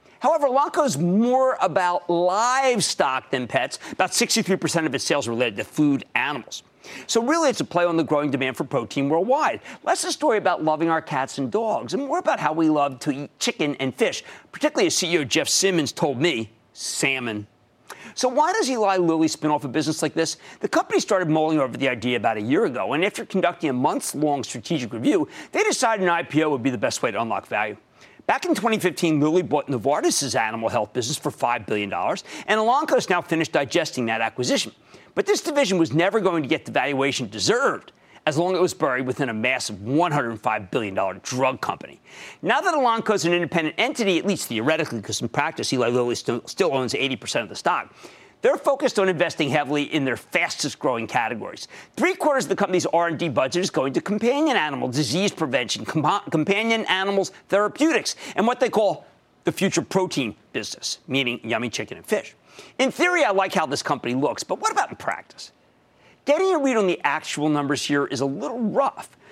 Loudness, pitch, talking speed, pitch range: -22 LUFS, 165 Hz, 200 wpm, 140-220 Hz